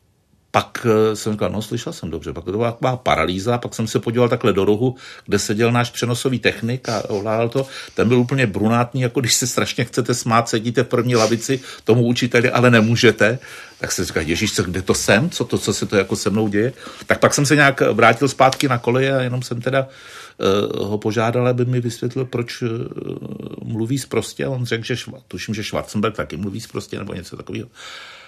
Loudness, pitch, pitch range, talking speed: -19 LUFS, 120 Hz, 110-130 Hz, 210 wpm